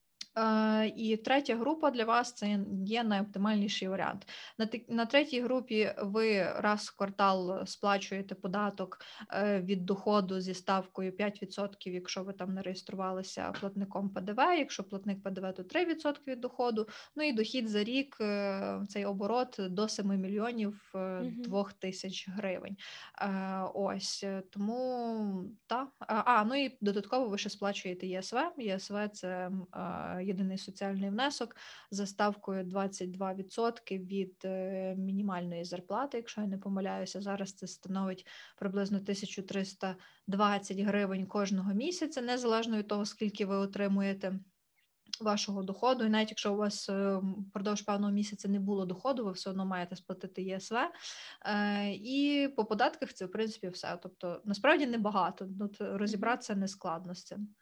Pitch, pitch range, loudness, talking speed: 200 Hz, 190-220 Hz, -34 LUFS, 130 wpm